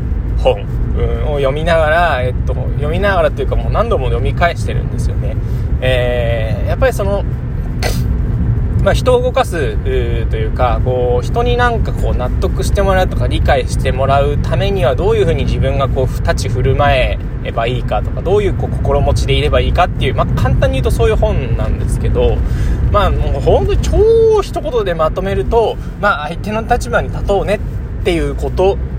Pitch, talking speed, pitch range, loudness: 120 Hz, 375 characters per minute, 110-130 Hz, -15 LUFS